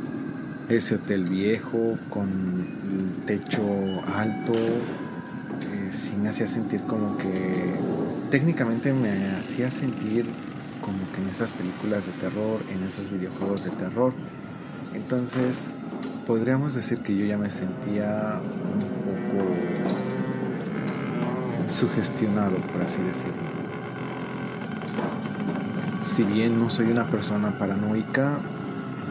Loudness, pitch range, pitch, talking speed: -27 LUFS, 100-135 Hz, 115 Hz, 105 wpm